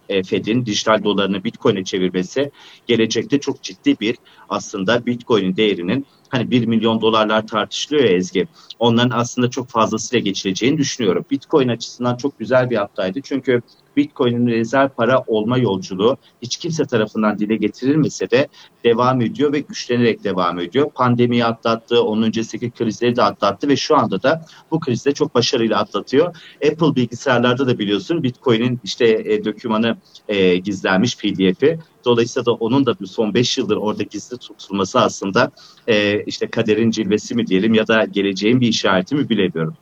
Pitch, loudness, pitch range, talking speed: 115 Hz, -18 LUFS, 105-125 Hz, 150 wpm